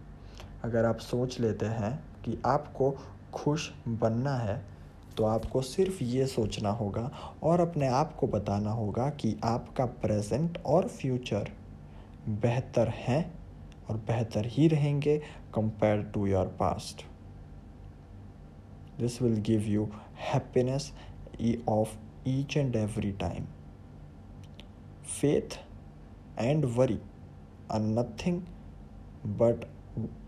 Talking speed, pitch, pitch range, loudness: 105 wpm, 110 Hz, 100-130 Hz, -31 LUFS